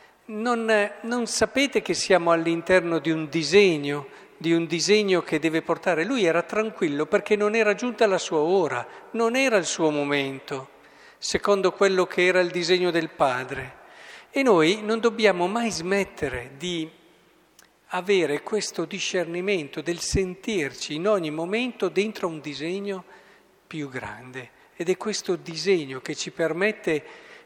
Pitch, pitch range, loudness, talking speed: 180 Hz, 165-210 Hz, -24 LUFS, 140 wpm